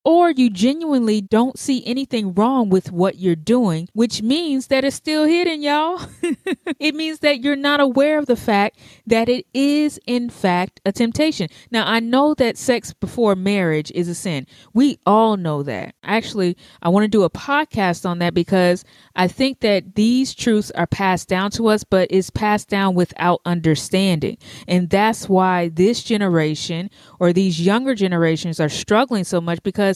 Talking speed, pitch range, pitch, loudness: 175 wpm, 180-255 Hz, 205 Hz, -18 LUFS